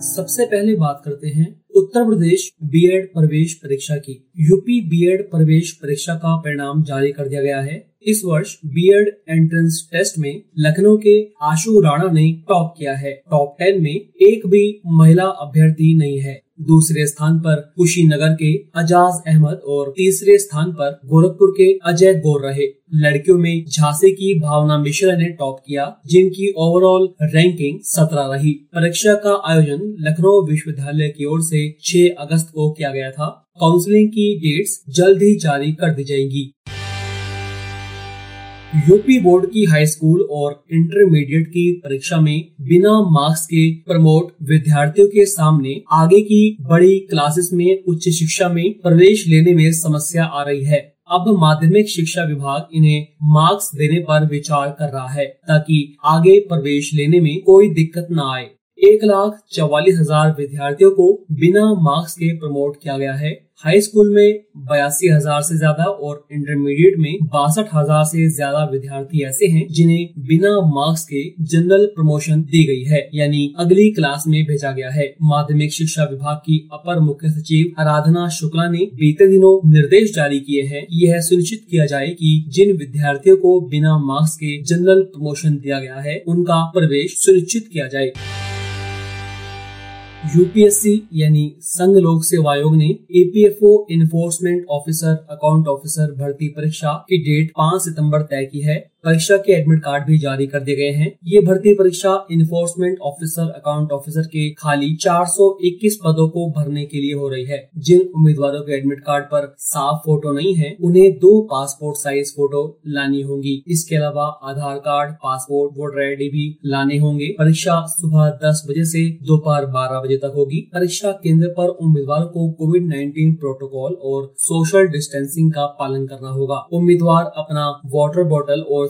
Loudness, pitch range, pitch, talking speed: -15 LUFS, 145-180 Hz, 155 Hz, 160 wpm